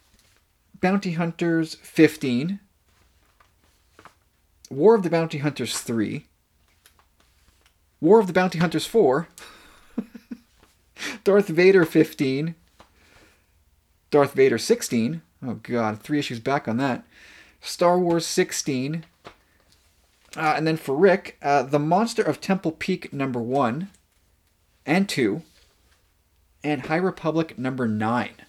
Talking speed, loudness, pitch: 105 wpm, -23 LUFS, 145 Hz